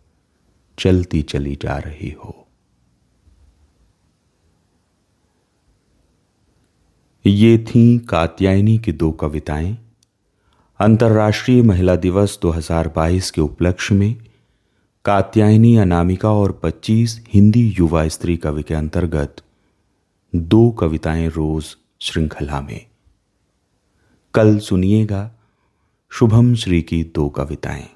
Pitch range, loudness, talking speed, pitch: 80-105 Hz, -16 LUFS, 85 wpm, 90 Hz